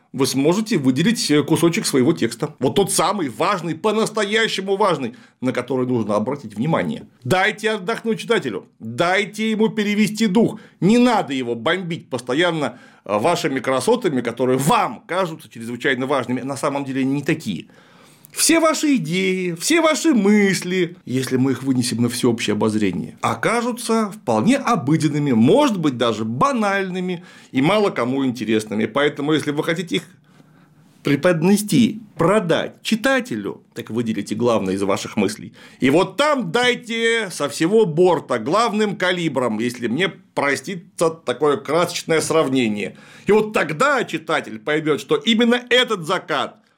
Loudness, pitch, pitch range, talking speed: -19 LUFS, 170 Hz, 135-215 Hz, 135 wpm